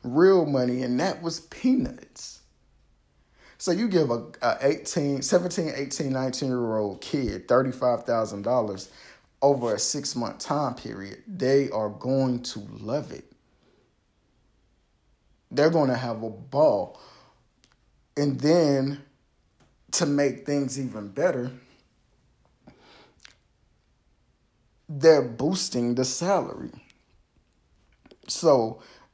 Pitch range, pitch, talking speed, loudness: 120-150 Hz, 130 Hz, 95 wpm, -25 LUFS